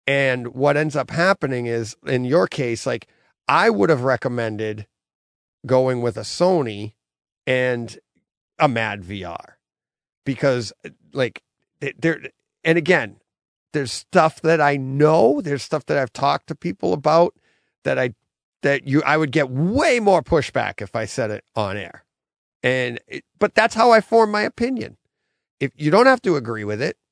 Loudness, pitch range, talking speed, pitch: -20 LUFS, 120-165 Hz, 160 wpm, 140 Hz